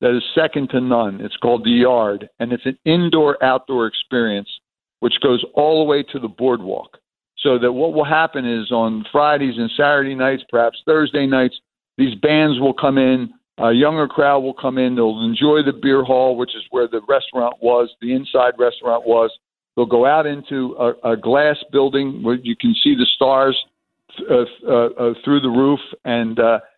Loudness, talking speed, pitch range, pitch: -17 LUFS, 190 wpm, 120-145 Hz, 130 Hz